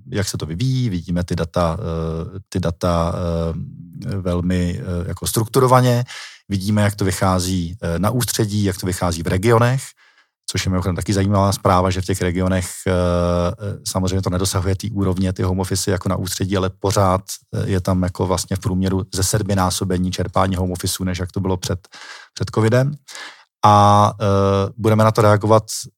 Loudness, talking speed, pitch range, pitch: -19 LUFS, 160 wpm, 90-105 Hz, 95 Hz